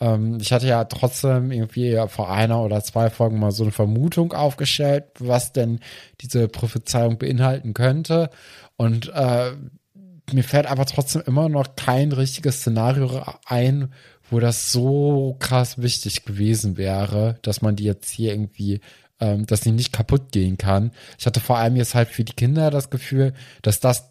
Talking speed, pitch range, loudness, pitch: 165 wpm, 110-135 Hz, -21 LUFS, 120 Hz